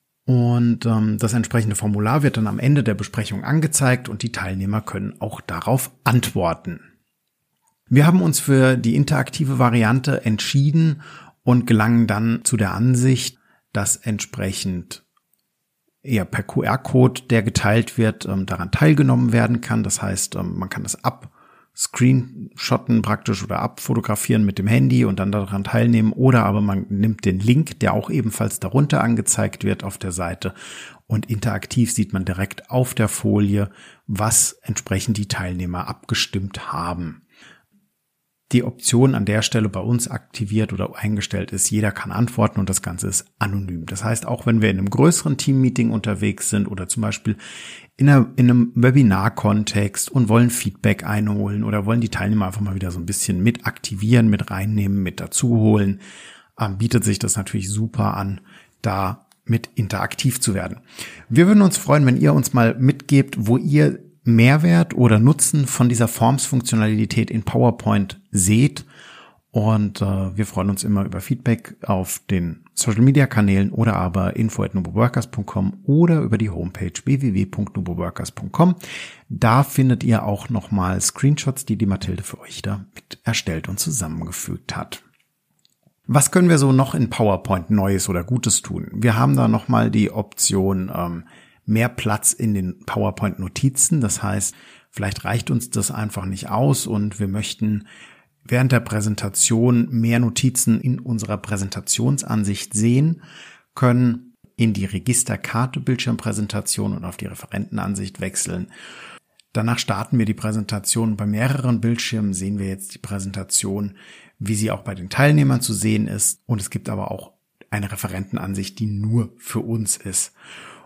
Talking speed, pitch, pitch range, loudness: 150 wpm, 110 Hz, 100-125 Hz, -20 LUFS